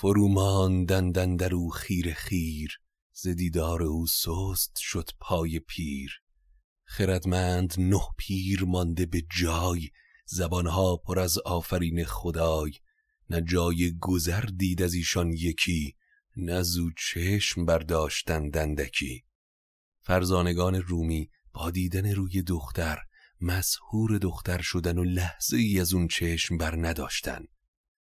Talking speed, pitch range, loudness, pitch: 110 wpm, 80-90 Hz, -28 LUFS, 90 Hz